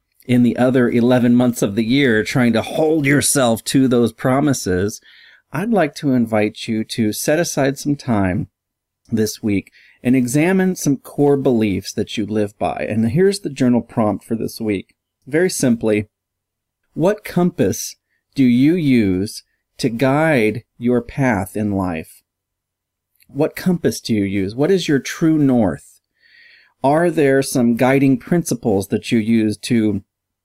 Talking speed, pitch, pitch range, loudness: 150 wpm, 120 Hz, 105-145 Hz, -17 LUFS